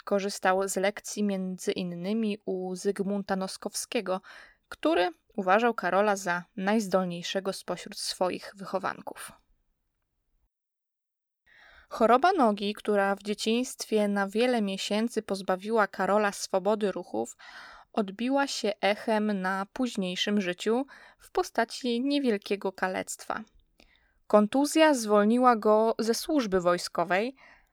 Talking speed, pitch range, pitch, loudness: 95 wpm, 195-235 Hz, 210 Hz, -28 LUFS